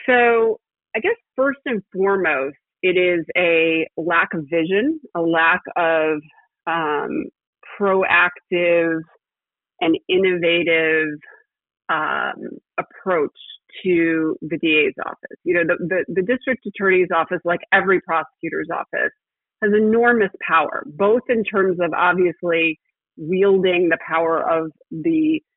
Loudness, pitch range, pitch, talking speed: -19 LUFS, 165-215 Hz, 180 Hz, 115 wpm